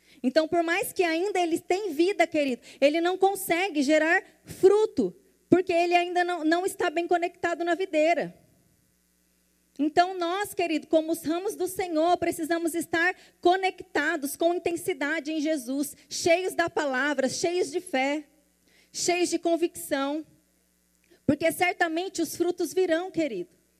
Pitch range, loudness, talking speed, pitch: 305-355 Hz, -26 LUFS, 135 wpm, 340 Hz